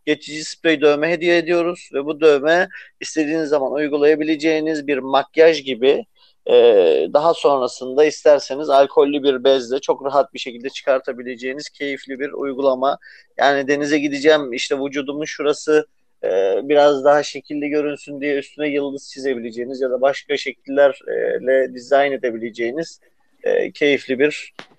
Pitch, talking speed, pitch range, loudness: 145 Hz, 120 wpm, 135-160 Hz, -18 LUFS